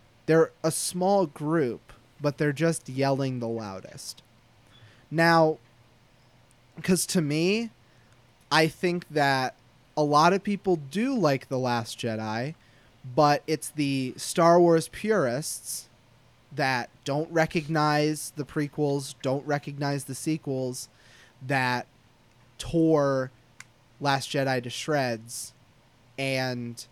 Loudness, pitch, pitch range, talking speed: -26 LUFS, 135 Hz, 120-155 Hz, 105 wpm